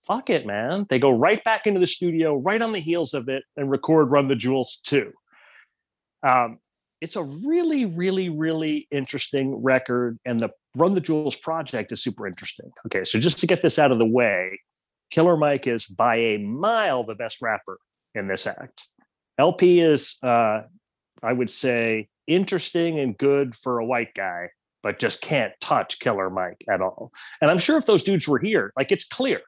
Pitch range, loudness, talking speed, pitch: 125-180 Hz, -22 LUFS, 190 wpm, 145 Hz